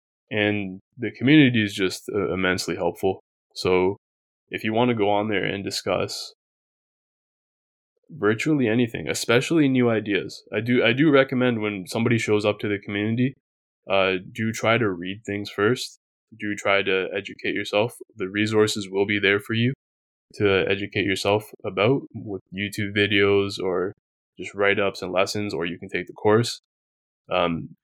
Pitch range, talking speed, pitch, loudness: 95-115 Hz, 155 wpm, 105 Hz, -23 LUFS